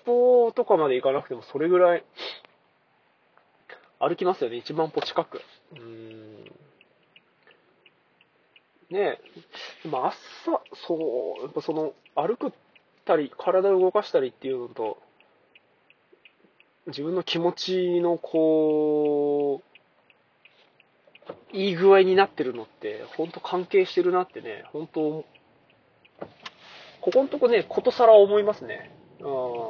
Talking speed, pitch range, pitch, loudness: 220 characters per minute, 155-215 Hz, 180 Hz, -24 LUFS